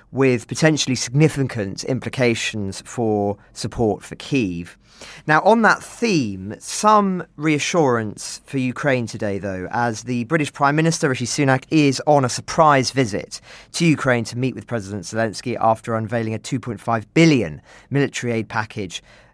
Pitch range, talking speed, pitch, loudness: 110-145 Hz, 140 wpm, 125 Hz, -20 LUFS